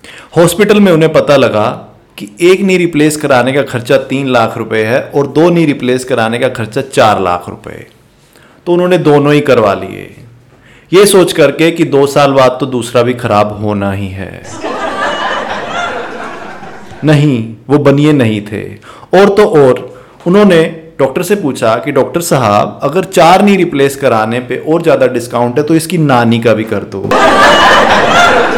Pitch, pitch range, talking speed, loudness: 140 Hz, 120-165 Hz, 160 wpm, -9 LUFS